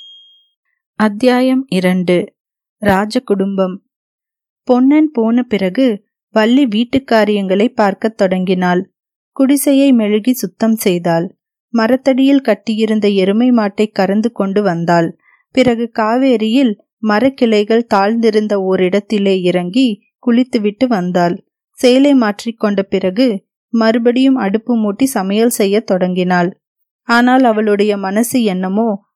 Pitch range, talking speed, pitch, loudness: 195-250 Hz, 85 wpm, 220 Hz, -13 LUFS